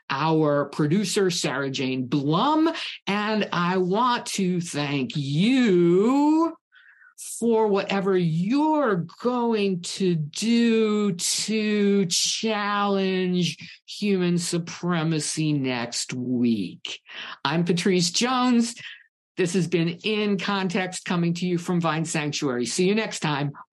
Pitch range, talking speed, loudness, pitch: 160-210 Hz, 105 wpm, -23 LUFS, 185 Hz